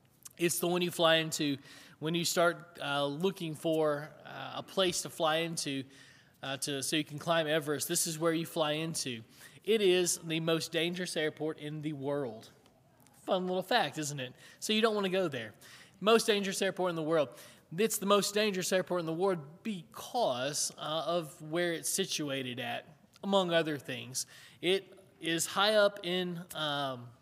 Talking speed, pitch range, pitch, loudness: 180 wpm, 145-180 Hz, 165 Hz, -32 LUFS